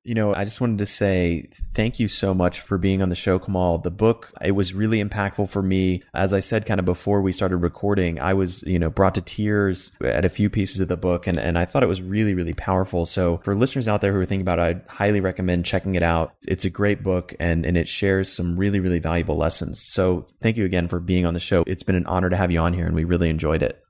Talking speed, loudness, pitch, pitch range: 275 wpm, -22 LUFS, 95 Hz, 85-100 Hz